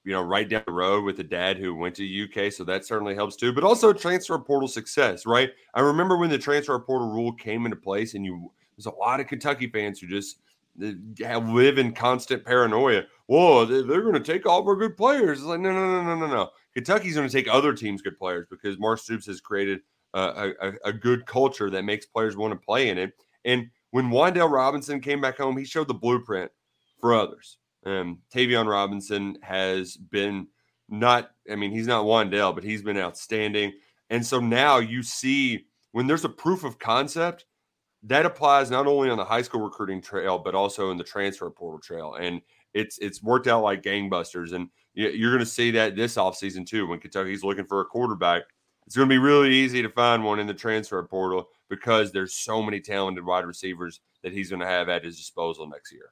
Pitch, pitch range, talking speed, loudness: 110 Hz, 95-130 Hz, 215 wpm, -24 LUFS